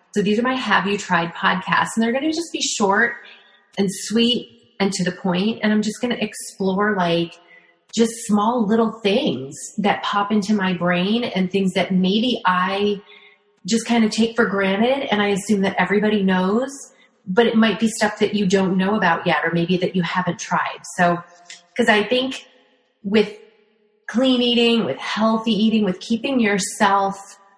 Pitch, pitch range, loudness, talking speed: 210 Hz, 190-230 Hz, -19 LUFS, 185 wpm